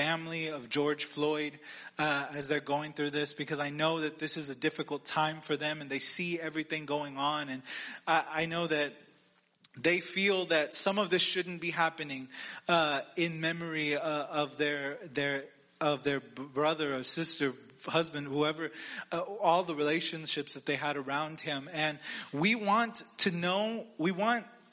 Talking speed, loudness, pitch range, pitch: 175 wpm, -31 LUFS, 145-165 Hz, 155 Hz